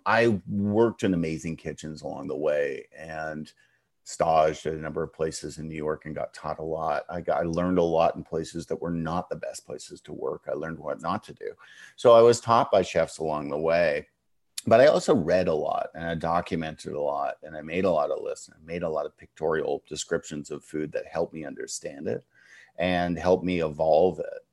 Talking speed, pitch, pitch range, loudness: 225 wpm, 85 Hz, 80-115 Hz, -26 LUFS